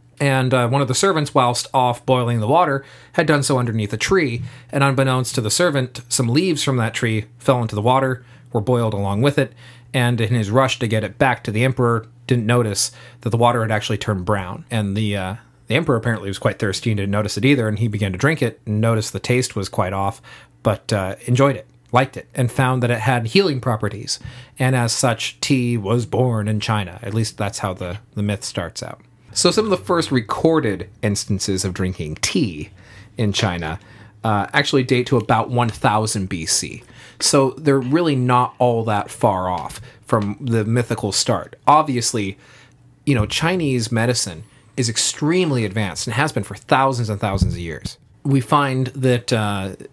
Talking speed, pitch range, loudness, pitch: 200 wpm, 105-130 Hz, -19 LUFS, 120 Hz